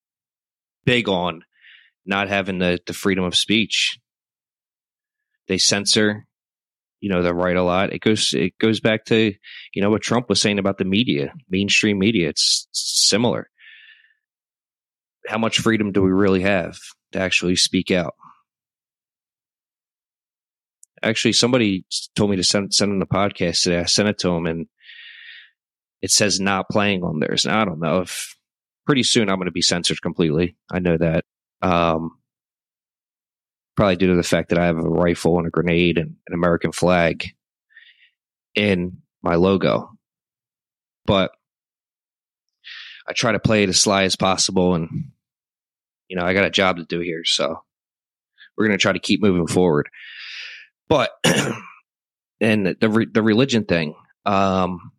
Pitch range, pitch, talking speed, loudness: 85-105 Hz, 95 Hz, 155 wpm, -19 LUFS